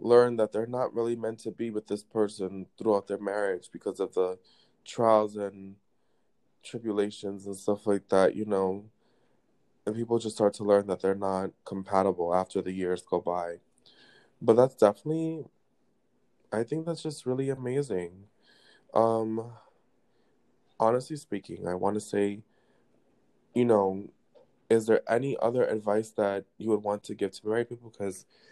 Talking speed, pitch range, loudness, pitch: 155 wpm, 95-115 Hz, -29 LUFS, 105 Hz